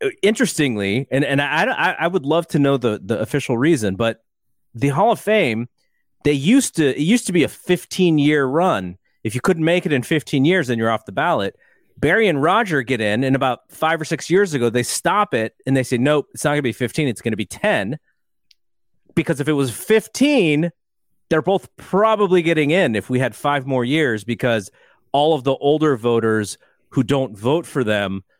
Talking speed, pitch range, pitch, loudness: 210 wpm, 120-165 Hz, 140 Hz, -19 LUFS